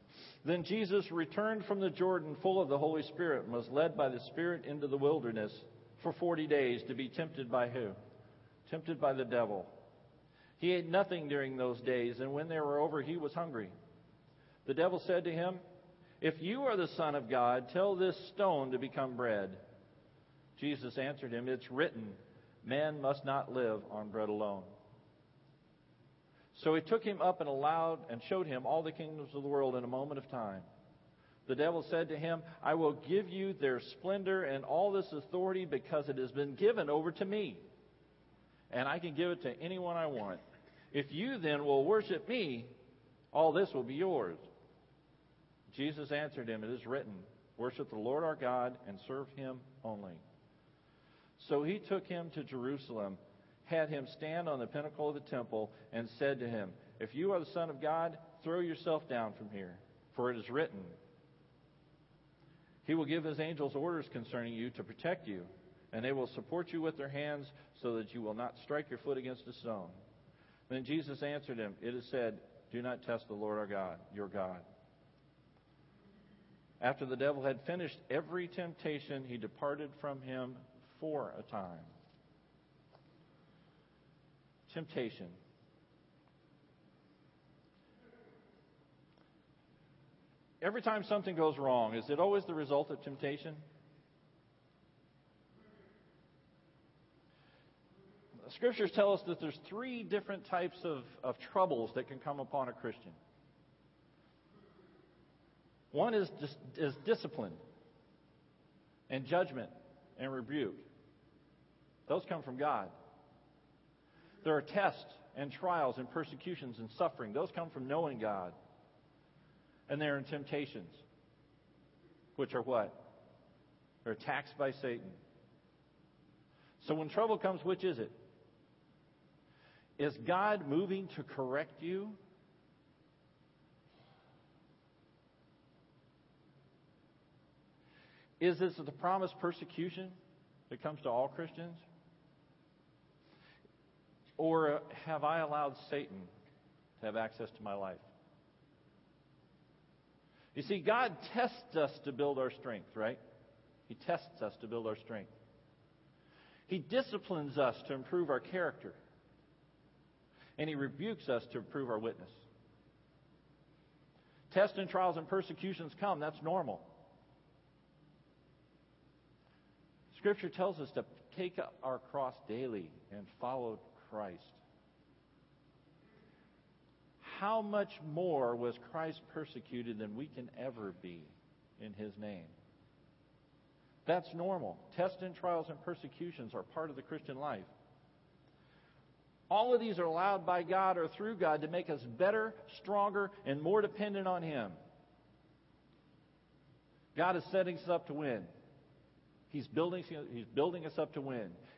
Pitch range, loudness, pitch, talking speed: 130-175 Hz, -38 LUFS, 150 Hz, 140 wpm